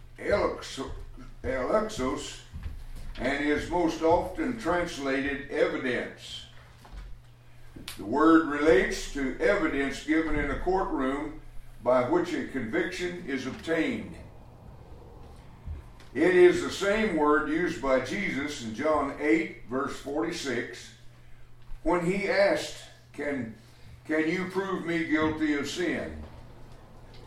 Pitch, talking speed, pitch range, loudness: 145 Hz, 100 wpm, 125-165 Hz, -28 LUFS